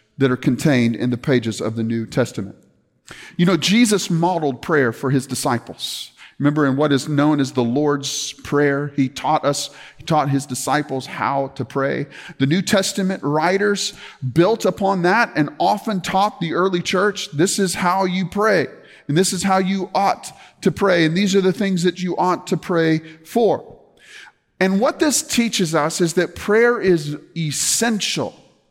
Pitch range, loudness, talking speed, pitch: 140-190 Hz, -19 LUFS, 175 wpm, 165 Hz